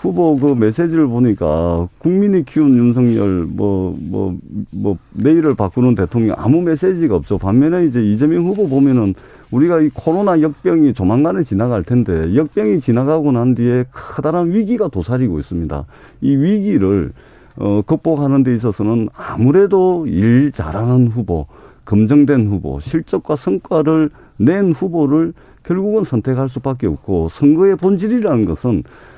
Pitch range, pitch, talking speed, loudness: 105-160 Hz, 130 Hz, 315 characters per minute, -15 LUFS